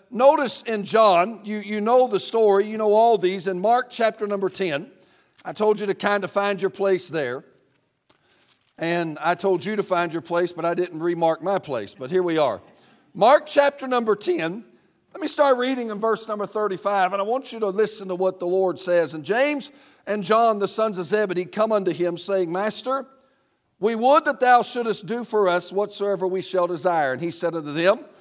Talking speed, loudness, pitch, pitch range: 210 wpm, -22 LUFS, 200 Hz, 180-225 Hz